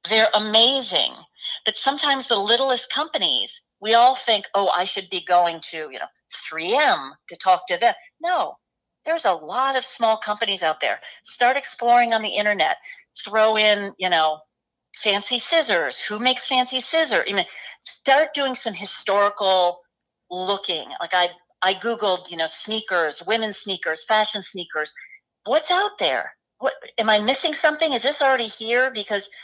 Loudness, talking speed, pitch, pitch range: -18 LUFS, 155 wpm, 220 Hz, 190-265 Hz